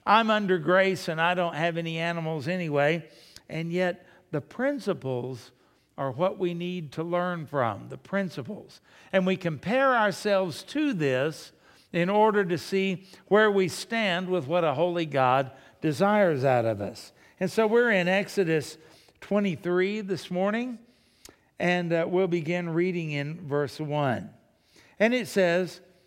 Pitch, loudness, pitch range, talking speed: 175 Hz, -26 LUFS, 155-195 Hz, 145 wpm